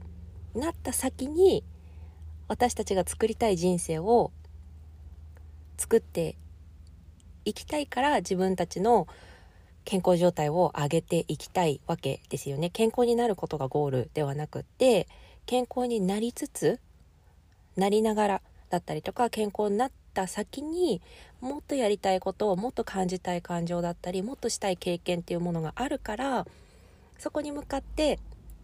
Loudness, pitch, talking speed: -29 LUFS, 185 Hz, 290 characters per minute